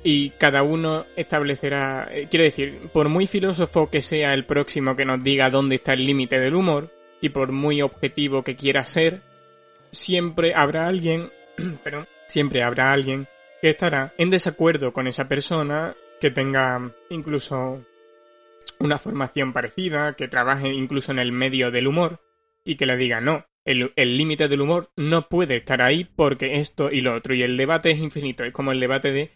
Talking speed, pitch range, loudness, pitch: 175 wpm, 135-160 Hz, -22 LUFS, 145 Hz